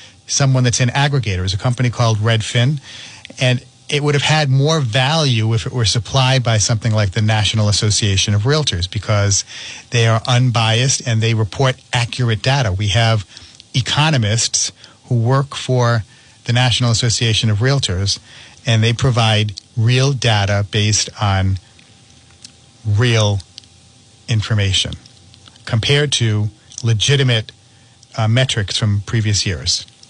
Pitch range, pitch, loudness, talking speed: 110-125 Hz, 115 Hz, -16 LUFS, 130 wpm